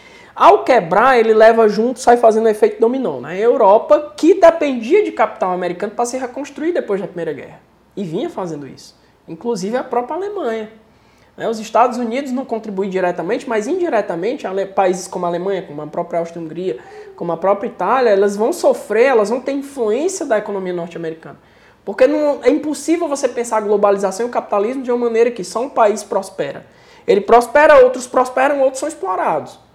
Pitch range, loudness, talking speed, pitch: 205-275 Hz, -16 LUFS, 180 wpm, 235 Hz